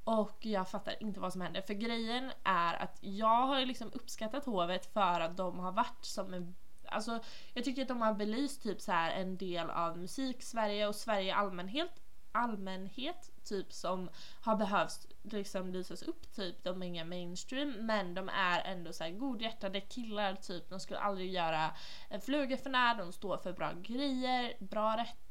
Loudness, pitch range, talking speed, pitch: -37 LUFS, 185-235 Hz, 180 wpm, 205 Hz